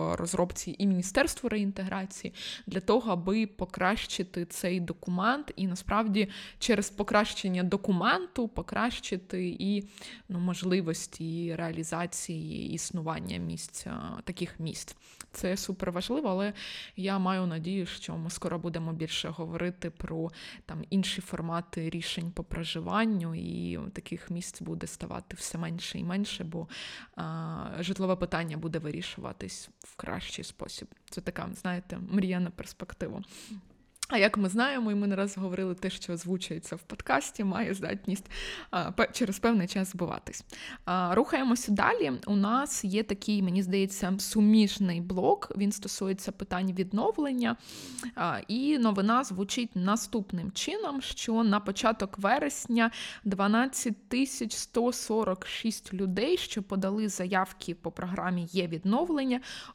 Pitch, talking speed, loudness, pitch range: 195 Hz, 125 wpm, -31 LUFS, 175-215 Hz